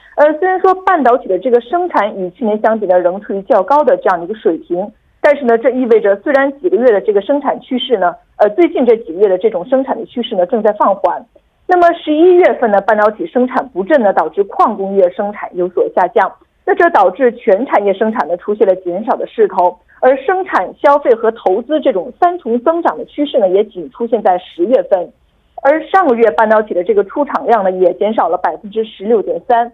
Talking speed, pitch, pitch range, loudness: 335 characters per minute, 250 Hz, 210-340 Hz, -13 LUFS